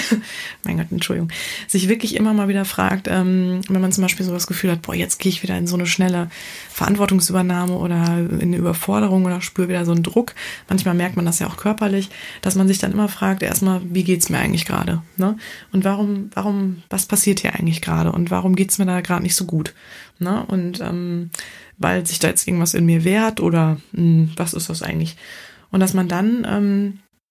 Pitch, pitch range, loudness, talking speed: 185 Hz, 175-195 Hz, -19 LUFS, 215 wpm